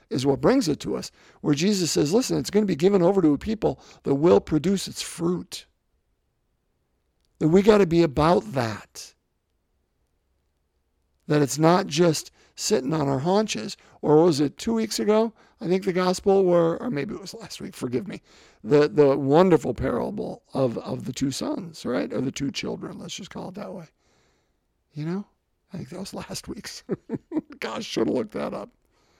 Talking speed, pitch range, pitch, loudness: 190 wpm, 140-195 Hz, 170 Hz, -23 LUFS